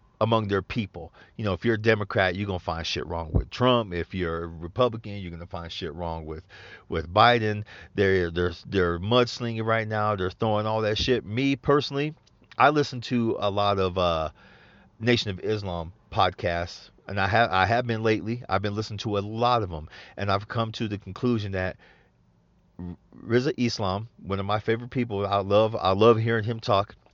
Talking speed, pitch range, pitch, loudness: 195 wpm, 95-115 Hz, 105 Hz, -26 LUFS